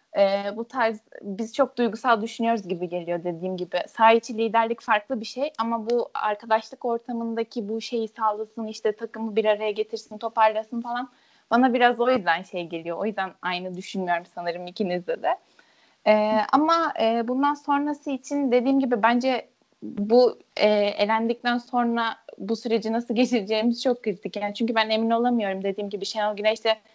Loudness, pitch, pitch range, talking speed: -24 LUFS, 225 Hz, 210-240 Hz, 160 wpm